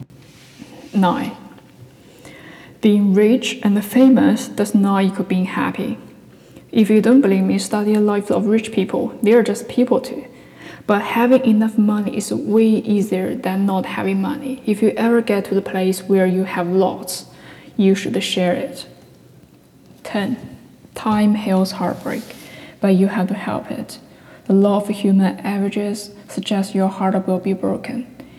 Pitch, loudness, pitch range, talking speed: 205 Hz, -18 LUFS, 195-225 Hz, 155 wpm